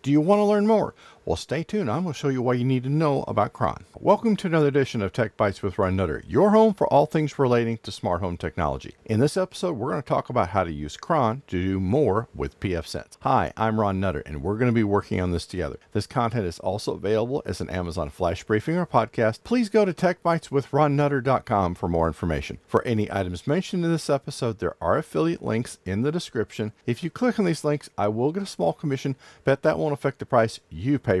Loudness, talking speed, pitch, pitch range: -24 LUFS, 240 wpm, 120 Hz, 100-150 Hz